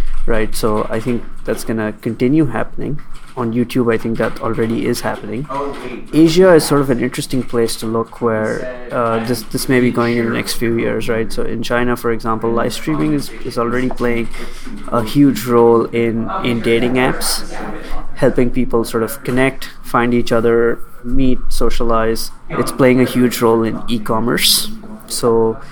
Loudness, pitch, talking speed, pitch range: -16 LUFS, 120 Hz, 175 wpm, 115-130 Hz